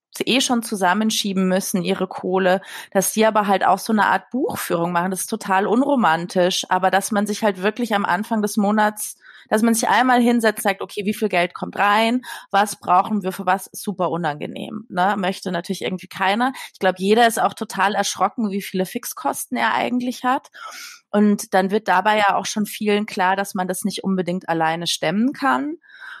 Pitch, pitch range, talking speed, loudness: 205 Hz, 185-220 Hz, 190 wpm, -20 LUFS